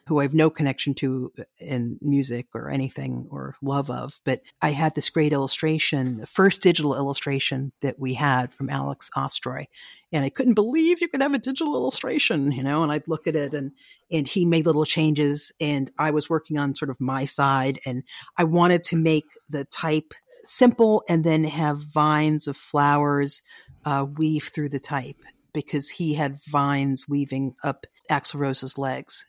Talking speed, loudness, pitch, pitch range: 180 wpm, -24 LUFS, 145 Hz, 135-160 Hz